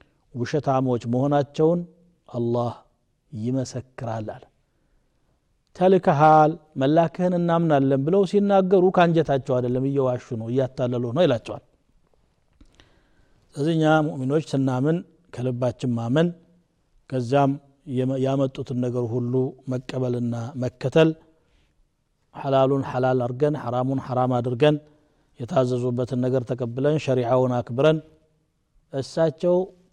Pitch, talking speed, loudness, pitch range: 135 Hz, 80 wpm, -23 LUFS, 125-155 Hz